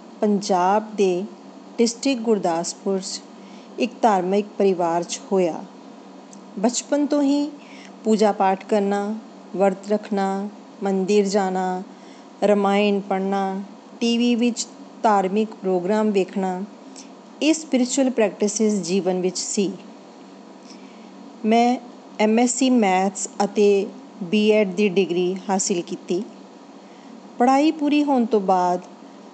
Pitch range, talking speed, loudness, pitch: 195-240 Hz, 95 wpm, -21 LUFS, 210 Hz